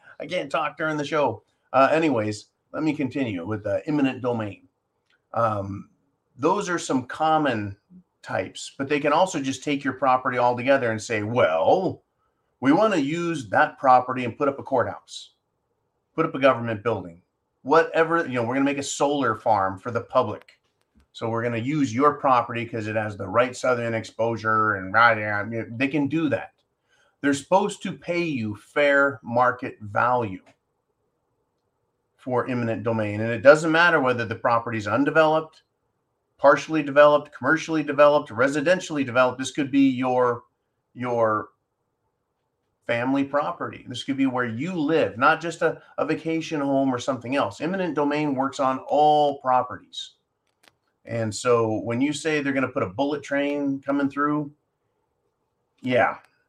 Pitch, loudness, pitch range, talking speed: 135 Hz, -23 LUFS, 115-150 Hz, 160 wpm